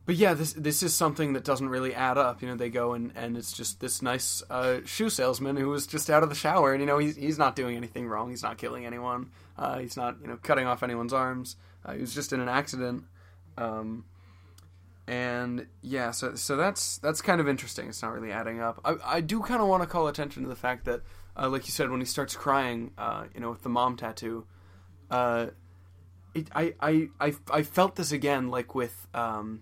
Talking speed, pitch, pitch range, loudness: 235 wpm, 125 Hz, 110-145 Hz, -29 LUFS